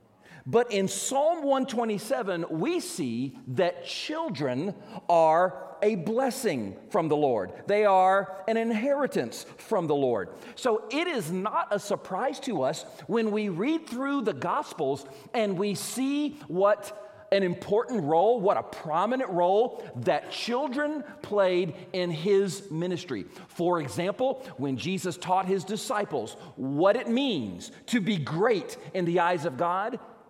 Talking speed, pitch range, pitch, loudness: 140 wpm, 180-245 Hz, 205 Hz, -28 LUFS